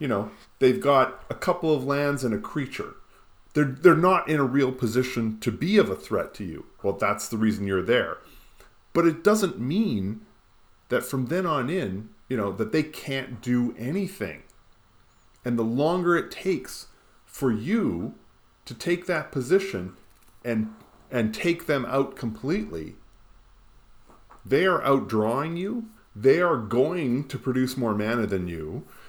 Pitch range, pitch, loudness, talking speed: 110-165 Hz, 130 Hz, -25 LUFS, 160 wpm